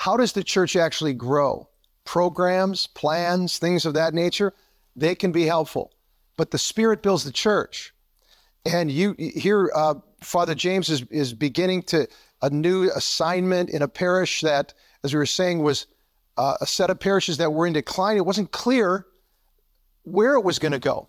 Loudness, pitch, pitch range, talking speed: -22 LUFS, 175 Hz, 155-185 Hz, 175 wpm